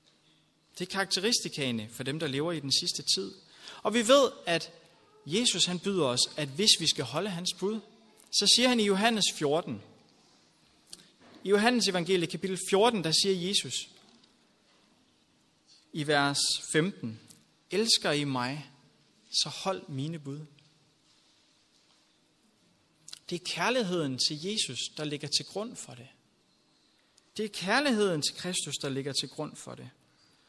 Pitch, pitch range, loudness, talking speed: 165 Hz, 145-200 Hz, -28 LUFS, 140 wpm